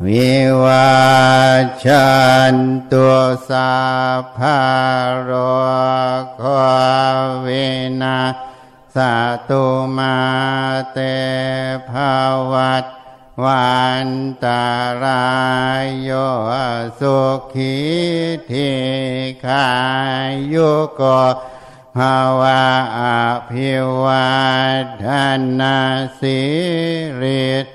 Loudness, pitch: -15 LUFS, 130 Hz